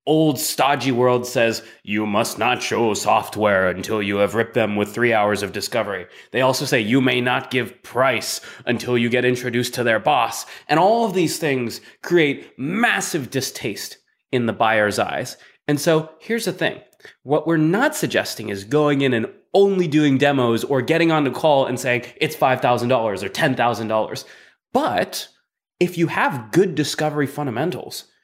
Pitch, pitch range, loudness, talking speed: 130 Hz, 115-155 Hz, -20 LUFS, 170 wpm